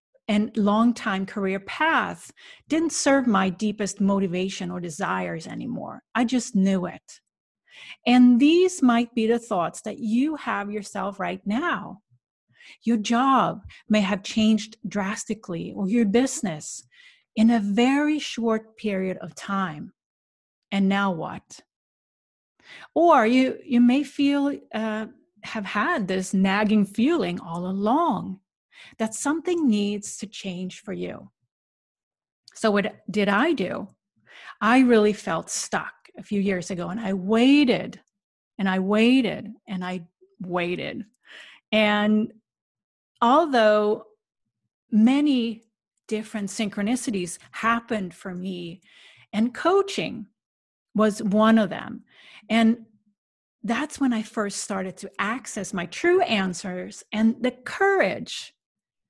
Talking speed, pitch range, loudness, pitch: 120 wpm, 195-240 Hz, -23 LUFS, 215 Hz